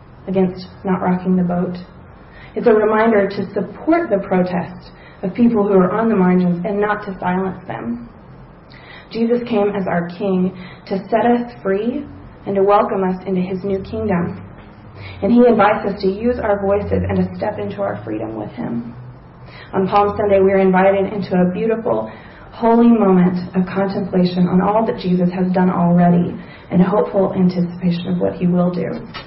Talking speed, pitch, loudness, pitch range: 175 wpm, 190 Hz, -17 LUFS, 175-205 Hz